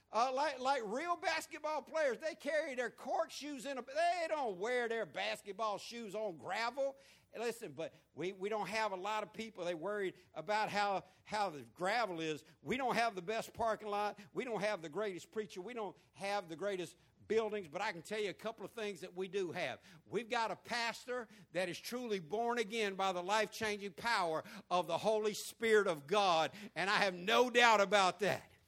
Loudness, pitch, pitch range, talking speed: -38 LUFS, 215 Hz, 190-235 Hz, 205 wpm